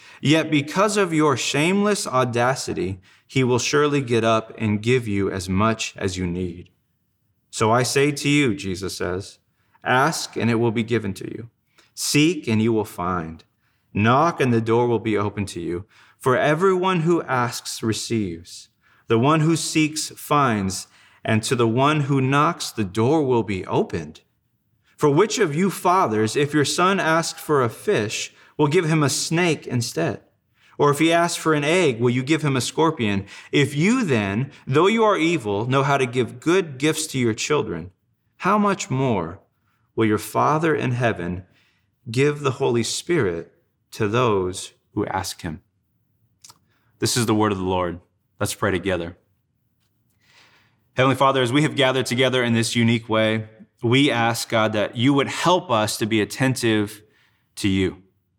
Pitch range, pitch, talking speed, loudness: 105-145 Hz, 120 Hz, 170 wpm, -21 LUFS